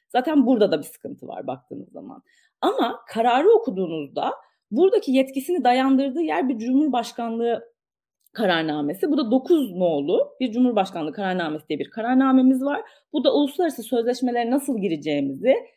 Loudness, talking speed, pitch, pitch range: -22 LUFS, 135 wpm, 260 Hz, 225-290 Hz